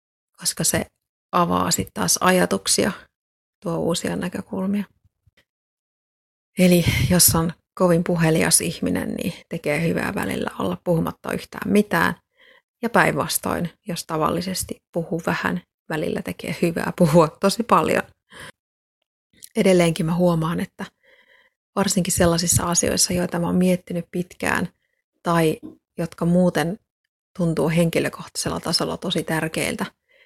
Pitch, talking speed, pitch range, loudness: 175 Hz, 110 wpm, 165-195 Hz, -21 LUFS